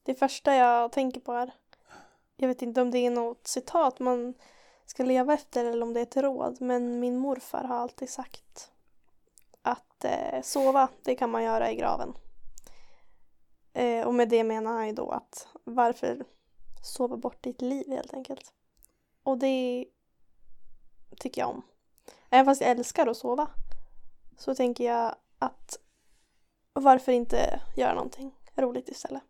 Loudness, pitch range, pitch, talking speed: -28 LUFS, 240-265 Hz, 250 Hz, 150 wpm